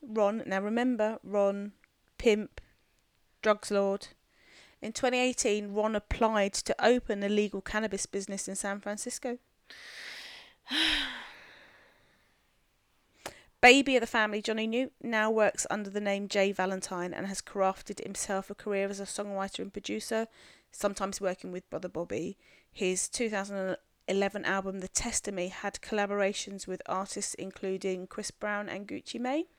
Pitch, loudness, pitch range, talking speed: 205 Hz, -31 LUFS, 195-220 Hz, 130 wpm